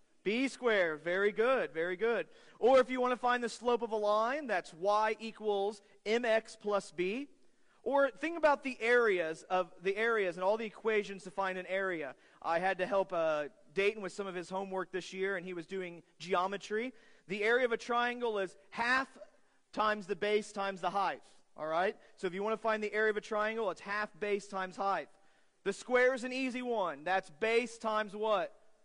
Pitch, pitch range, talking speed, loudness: 210 Hz, 190-230 Hz, 205 wpm, -34 LUFS